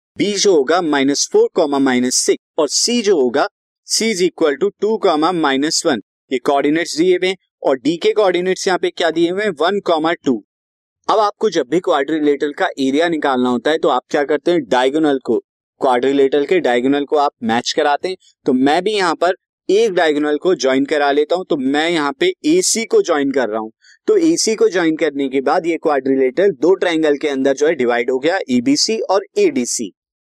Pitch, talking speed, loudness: 165 Hz, 205 wpm, -16 LUFS